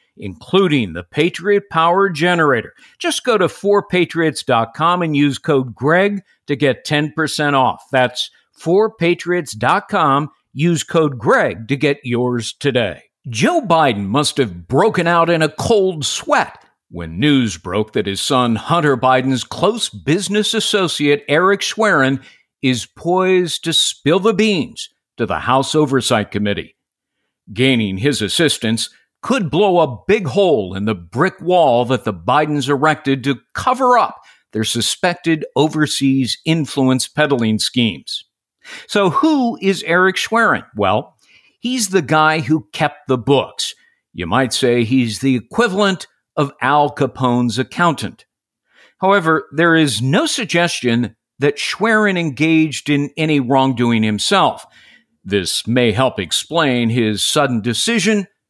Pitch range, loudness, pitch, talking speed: 125-180 Hz, -16 LUFS, 145 Hz, 130 wpm